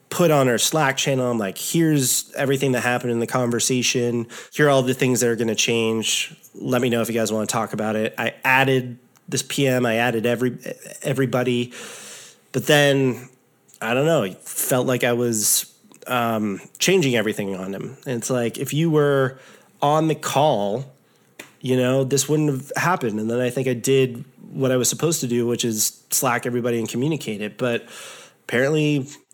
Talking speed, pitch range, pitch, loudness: 190 wpm, 120-135 Hz, 125 Hz, -21 LUFS